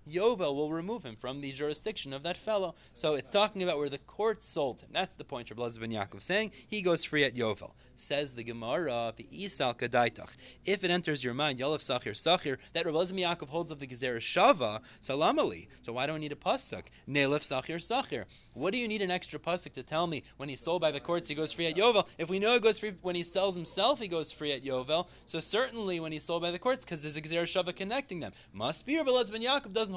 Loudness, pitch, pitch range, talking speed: -31 LUFS, 165 Hz, 140-185 Hz, 235 wpm